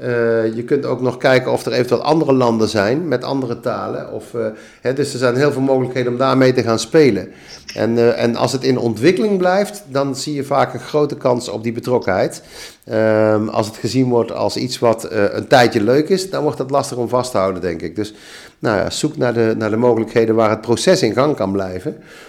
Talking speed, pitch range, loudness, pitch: 235 wpm, 110-135 Hz, -17 LUFS, 125 Hz